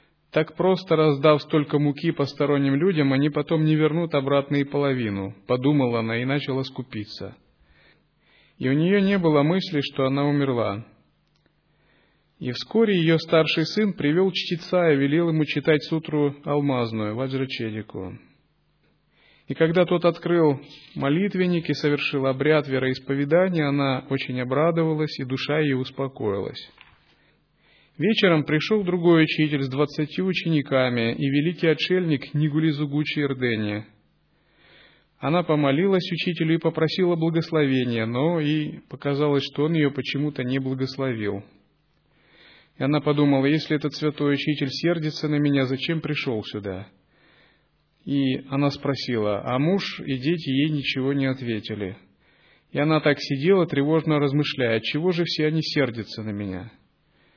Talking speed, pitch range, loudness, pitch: 125 wpm, 130-160 Hz, -23 LUFS, 145 Hz